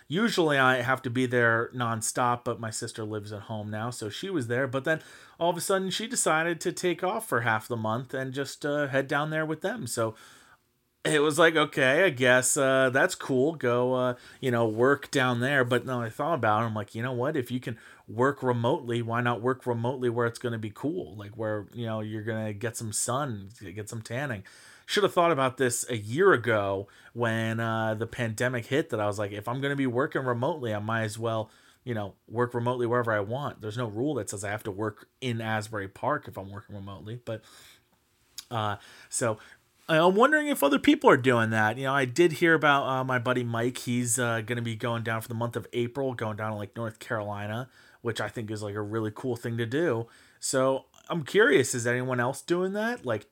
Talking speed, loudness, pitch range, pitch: 235 wpm, -27 LUFS, 110-135 Hz, 120 Hz